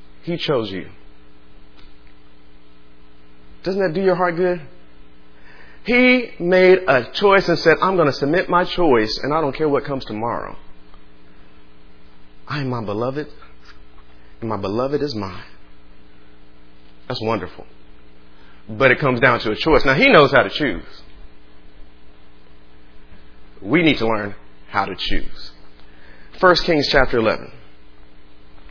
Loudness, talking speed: -18 LUFS, 130 wpm